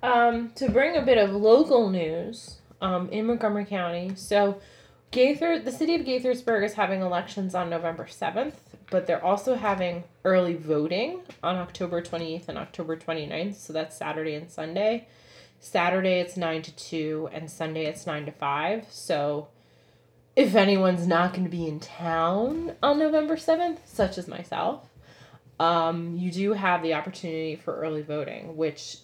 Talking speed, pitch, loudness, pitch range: 160 wpm, 180 Hz, -26 LUFS, 165-220 Hz